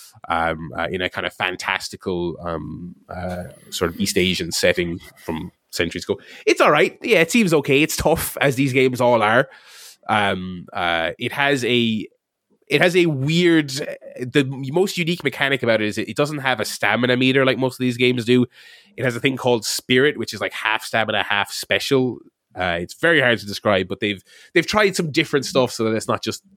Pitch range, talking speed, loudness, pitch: 105-140 Hz, 205 wpm, -20 LUFS, 125 Hz